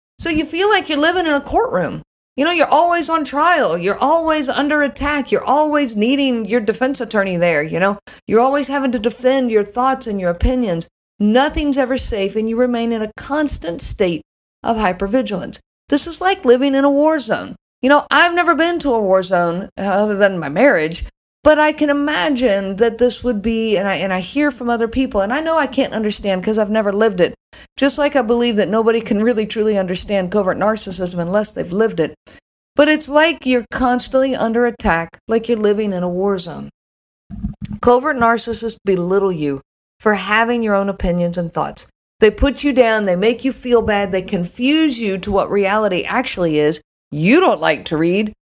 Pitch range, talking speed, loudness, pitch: 195-275 Hz, 200 wpm, -16 LUFS, 230 Hz